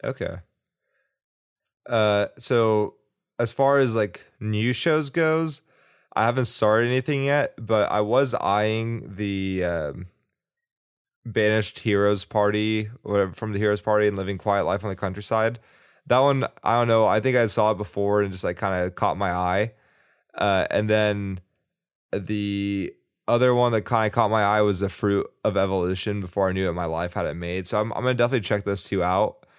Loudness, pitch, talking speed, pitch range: -23 LUFS, 105 Hz, 185 wpm, 100-115 Hz